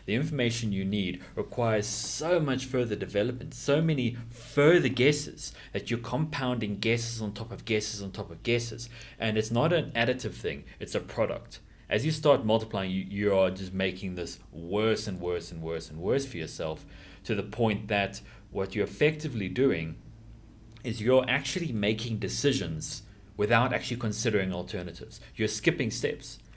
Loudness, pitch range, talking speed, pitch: -29 LUFS, 100-125 Hz, 165 wpm, 110 Hz